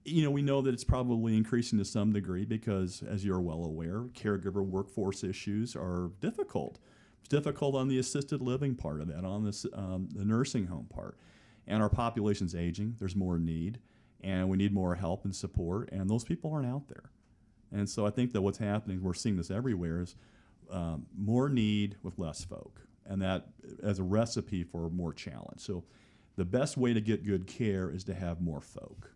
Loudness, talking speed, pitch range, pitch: -34 LUFS, 200 wpm, 95-115 Hz, 100 Hz